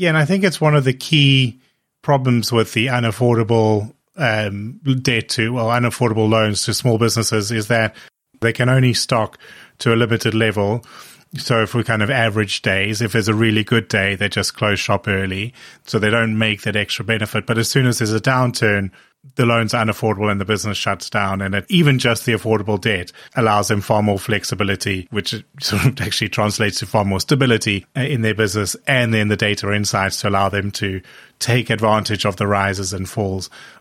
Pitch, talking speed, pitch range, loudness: 110 Hz, 200 wpm, 105-120 Hz, -18 LUFS